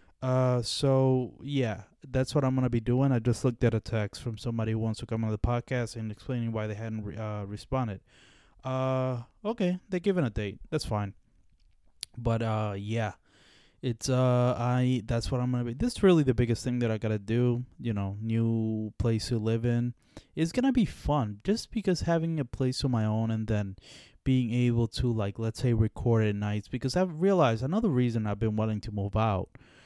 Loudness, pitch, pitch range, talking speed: -29 LUFS, 120 Hz, 110-130 Hz, 205 wpm